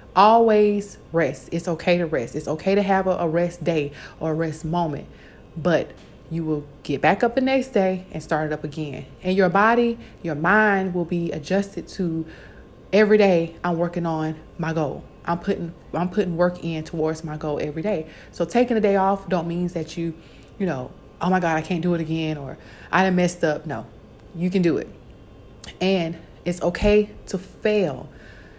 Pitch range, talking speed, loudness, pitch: 155-190 Hz, 195 wpm, -22 LUFS, 170 Hz